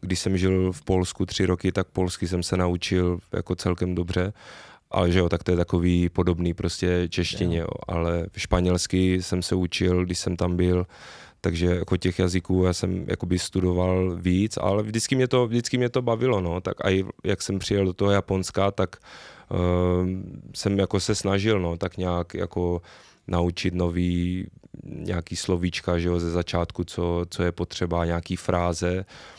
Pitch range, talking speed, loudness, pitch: 90-95 Hz, 175 wpm, -25 LUFS, 90 Hz